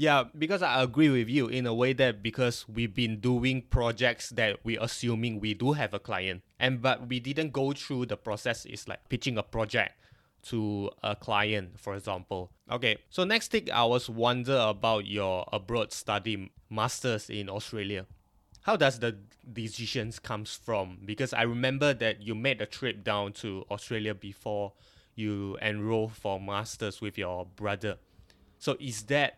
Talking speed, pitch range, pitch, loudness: 170 wpm, 100-125 Hz, 110 Hz, -30 LUFS